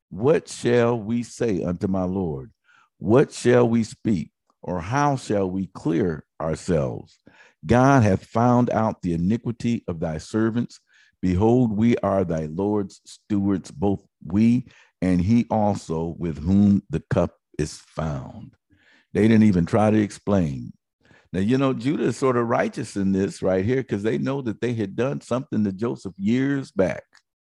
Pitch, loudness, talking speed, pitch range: 105 Hz, -23 LUFS, 160 wpm, 95-120 Hz